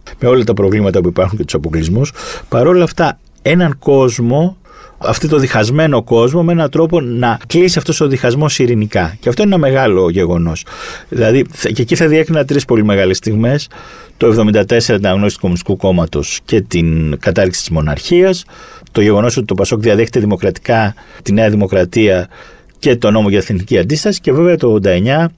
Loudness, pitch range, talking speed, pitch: -12 LUFS, 100-155 Hz, 175 wpm, 120 Hz